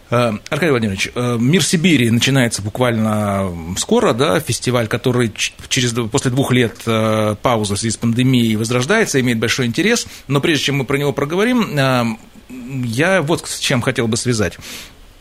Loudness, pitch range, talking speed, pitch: -16 LUFS, 115-140 Hz, 145 wpm, 125 Hz